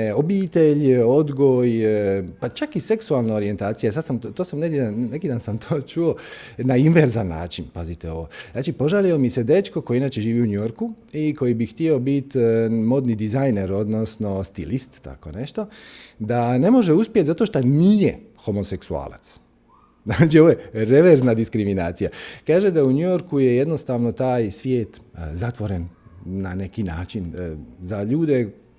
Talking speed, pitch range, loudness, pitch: 145 wpm, 105-150 Hz, -20 LUFS, 120 Hz